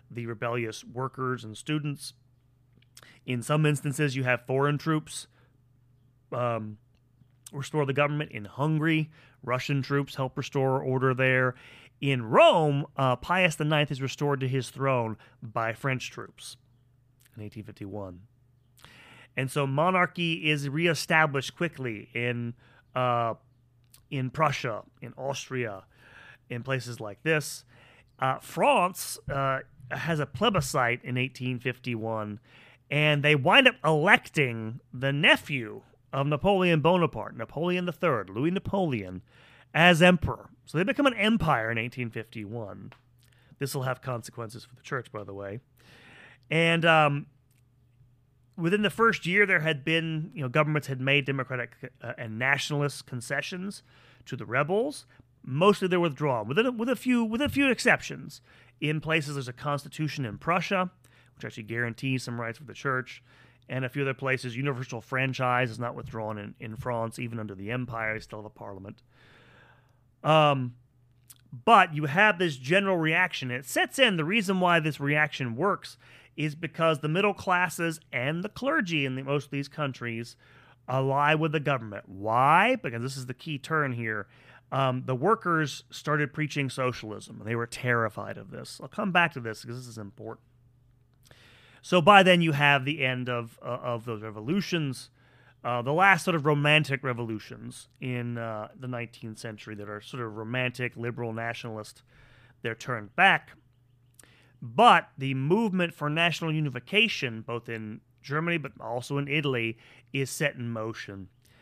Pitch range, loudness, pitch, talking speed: 120-150 Hz, -27 LUFS, 130 Hz, 150 wpm